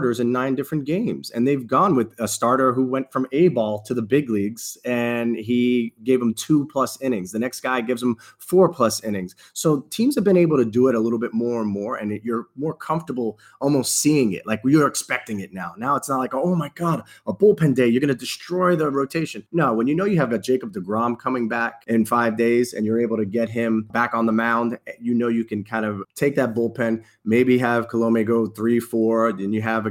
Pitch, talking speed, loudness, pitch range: 120 Hz, 245 wpm, -21 LUFS, 115-135 Hz